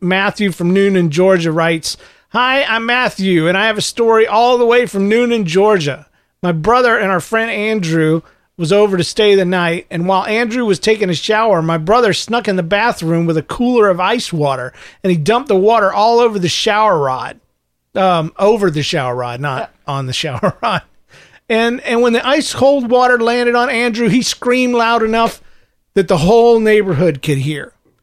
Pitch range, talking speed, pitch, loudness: 175-235 Hz, 195 wpm, 205 Hz, -13 LUFS